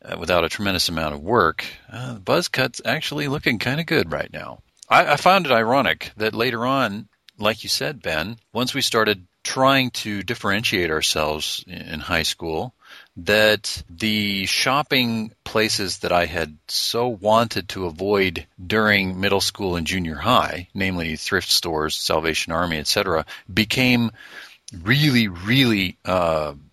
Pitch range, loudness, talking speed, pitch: 90-120 Hz, -20 LUFS, 150 wpm, 105 Hz